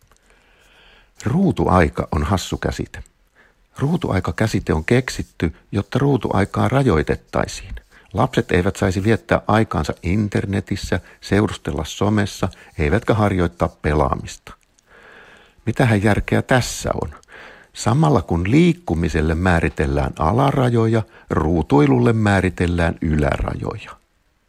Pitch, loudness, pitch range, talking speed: 100 Hz, -19 LUFS, 85-115 Hz, 80 wpm